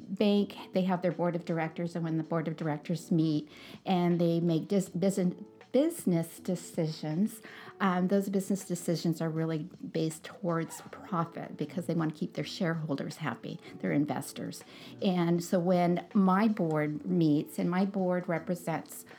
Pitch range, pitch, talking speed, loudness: 165-190 Hz, 175 Hz, 155 wpm, -31 LUFS